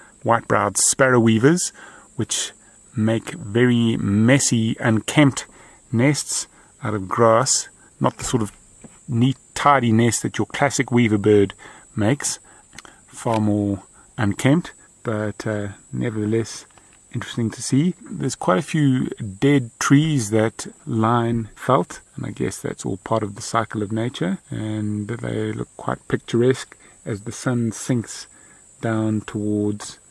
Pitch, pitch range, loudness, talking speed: 115 Hz, 110-135 Hz, -21 LUFS, 130 wpm